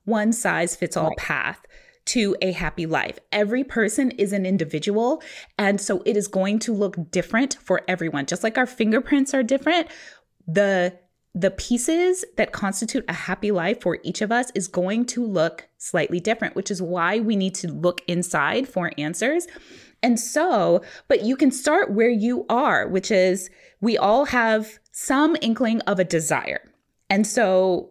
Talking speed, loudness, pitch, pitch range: 170 wpm, -22 LUFS, 210 Hz, 185-245 Hz